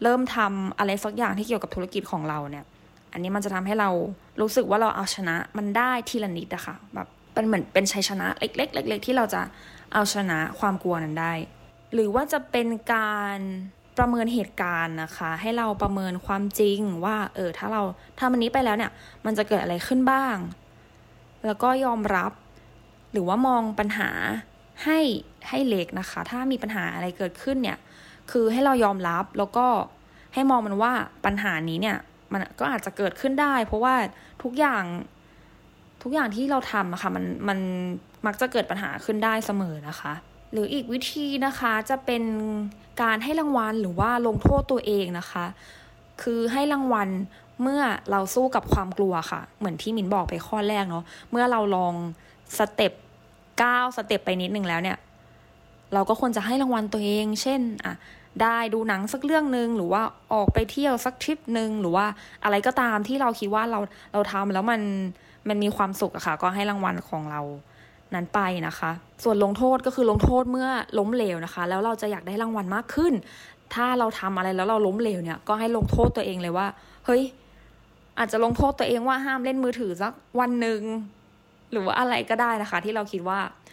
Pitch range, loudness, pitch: 190-240 Hz, -26 LUFS, 210 Hz